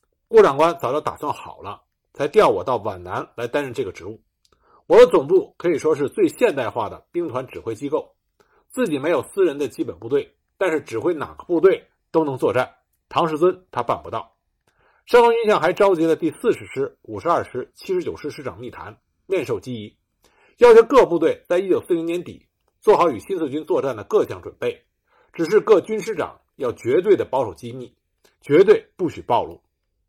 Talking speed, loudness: 285 characters per minute, -20 LUFS